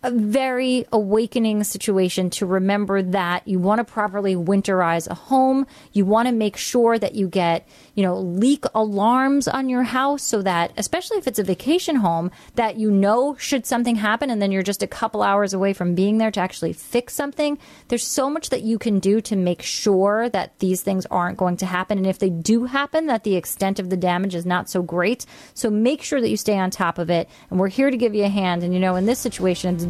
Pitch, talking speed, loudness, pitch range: 210 Hz, 230 wpm, -21 LUFS, 185-245 Hz